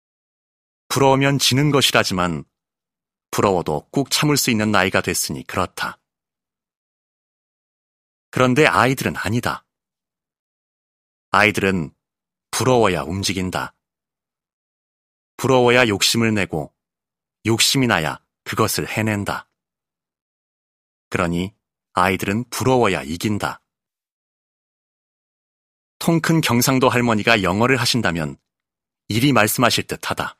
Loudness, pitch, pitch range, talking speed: -18 LUFS, 110 Hz, 90-125 Hz, 220 characters per minute